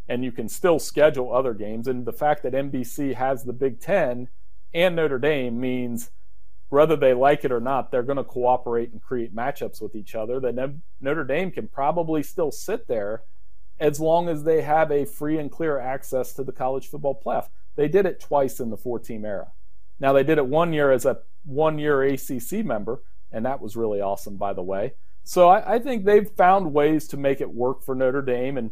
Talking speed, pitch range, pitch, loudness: 210 wpm, 120-150 Hz, 130 Hz, -23 LUFS